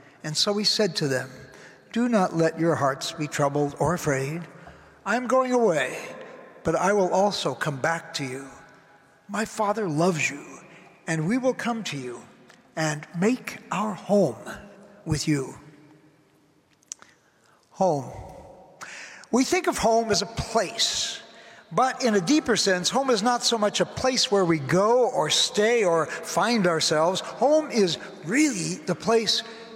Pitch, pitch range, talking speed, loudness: 190 Hz, 155-230 Hz, 155 wpm, -24 LUFS